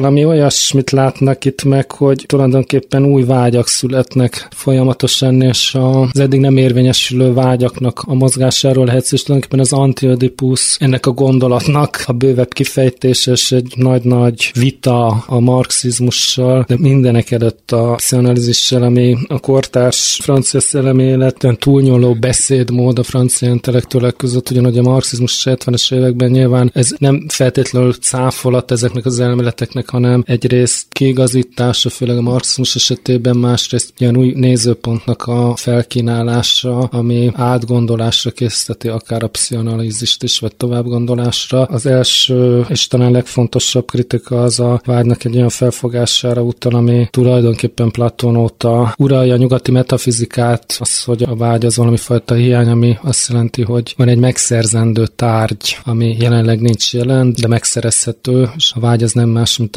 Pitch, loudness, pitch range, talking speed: 125 Hz, -12 LUFS, 120-130 Hz, 135 wpm